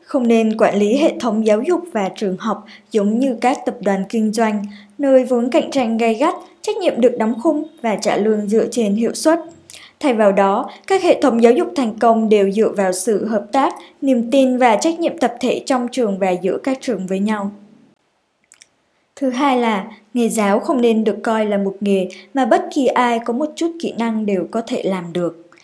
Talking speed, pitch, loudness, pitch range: 220 wpm, 230 Hz, -17 LUFS, 210-265 Hz